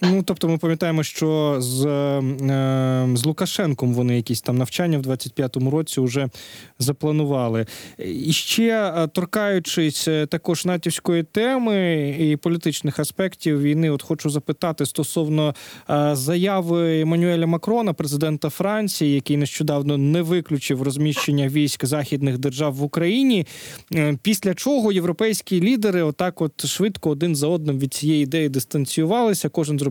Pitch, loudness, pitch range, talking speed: 155 Hz, -21 LUFS, 145-175 Hz, 125 wpm